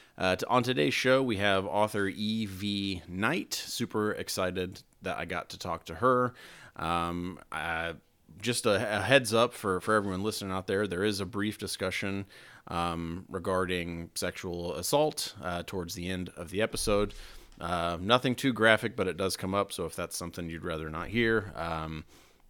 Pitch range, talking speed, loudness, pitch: 85-110 Hz, 175 wpm, -30 LUFS, 95 Hz